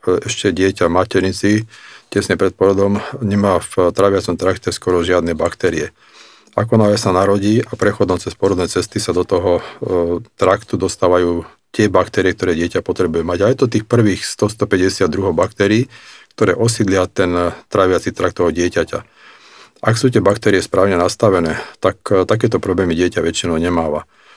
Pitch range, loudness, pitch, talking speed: 90-110 Hz, -16 LUFS, 100 Hz, 145 wpm